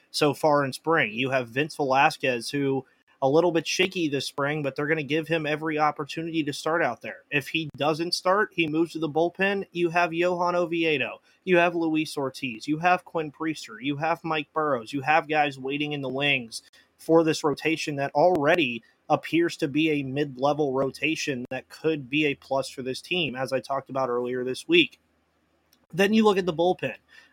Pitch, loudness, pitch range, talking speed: 155 Hz, -25 LUFS, 135-165 Hz, 200 wpm